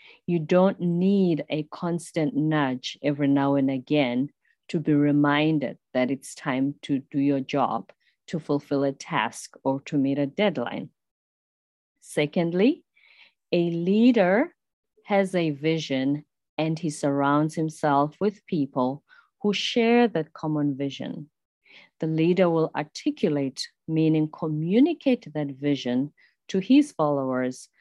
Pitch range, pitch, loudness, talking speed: 140-180 Hz, 155 Hz, -25 LUFS, 125 wpm